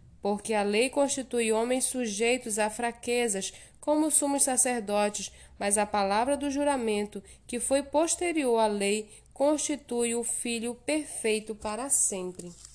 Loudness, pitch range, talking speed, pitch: -28 LUFS, 210-275 Hz, 125 wpm, 235 Hz